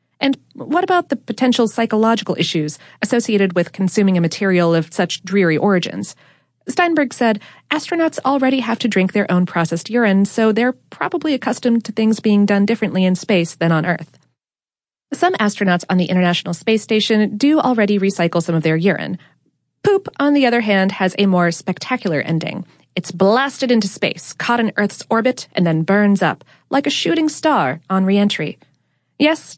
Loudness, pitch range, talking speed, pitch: -17 LUFS, 180-245 Hz, 170 wpm, 205 Hz